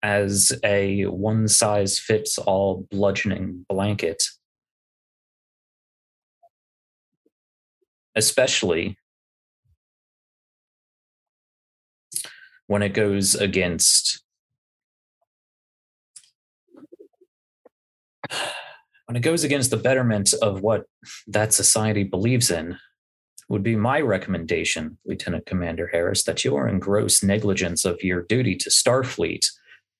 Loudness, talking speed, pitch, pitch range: -21 LUFS, 90 wpm, 100 Hz, 95-110 Hz